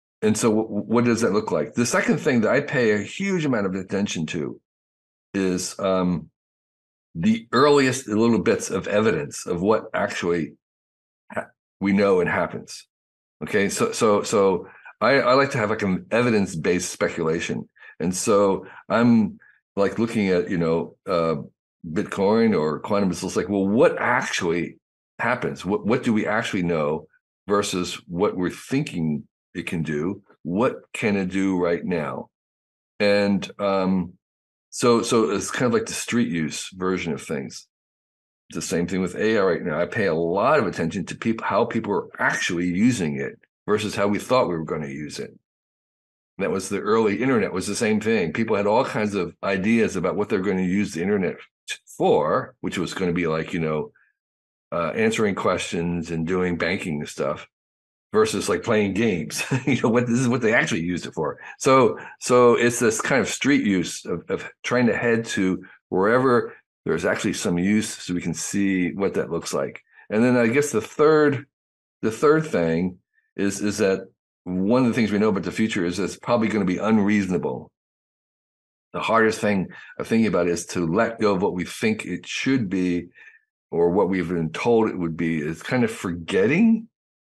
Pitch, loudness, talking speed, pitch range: 95 Hz, -22 LUFS, 185 wpm, 85-115 Hz